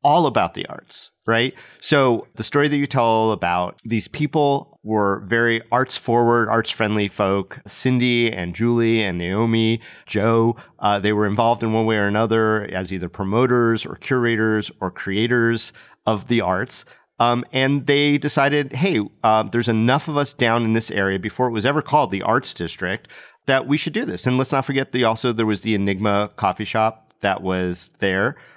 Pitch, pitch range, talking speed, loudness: 115 Hz, 105-125 Hz, 185 wpm, -20 LUFS